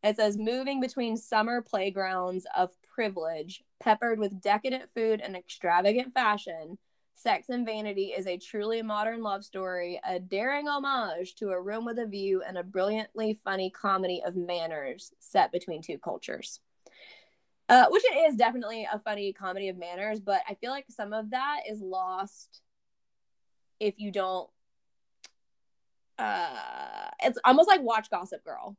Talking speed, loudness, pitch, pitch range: 150 wpm, -29 LUFS, 210 Hz, 190-240 Hz